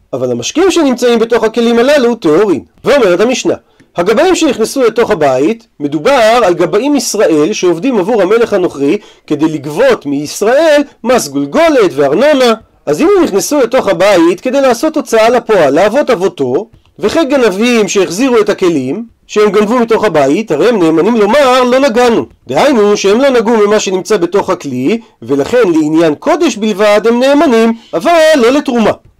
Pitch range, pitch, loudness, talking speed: 195-285 Hz, 230 Hz, -9 LUFS, 145 wpm